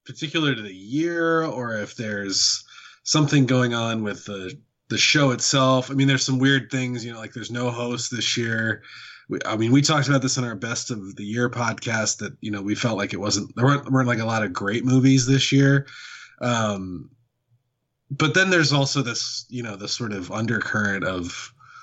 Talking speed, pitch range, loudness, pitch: 210 wpm, 110-135 Hz, -22 LUFS, 120 Hz